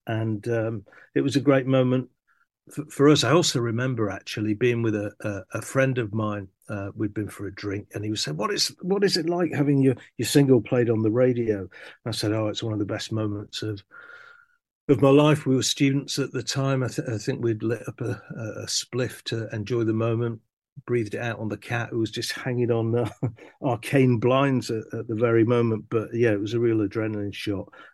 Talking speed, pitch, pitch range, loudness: 235 wpm, 120 Hz, 110-135 Hz, -25 LUFS